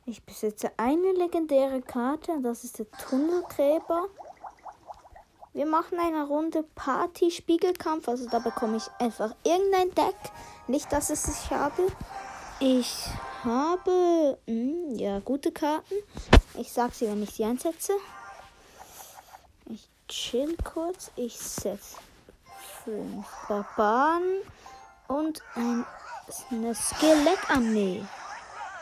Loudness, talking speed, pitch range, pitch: -28 LUFS, 100 wpm, 235-345 Hz, 285 Hz